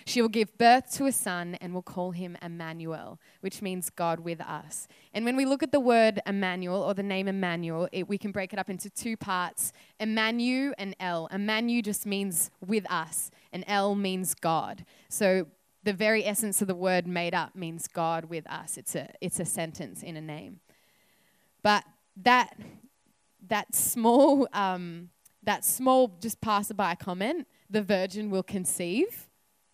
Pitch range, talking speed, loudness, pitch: 180-220 Hz, 170 wpm, -28 LUFS, 195 Hz